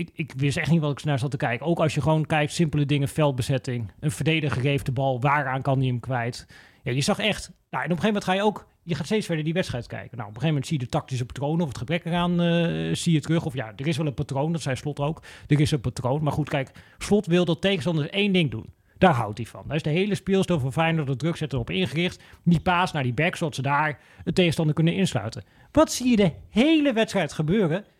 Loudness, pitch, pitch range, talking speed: -24 LUFS, 155 Hz, 135-175 Hz, 270 wpm